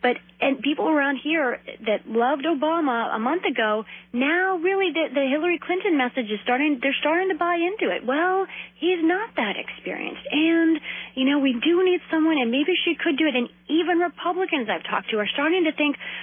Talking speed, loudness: 200 wpm, -23 LUFS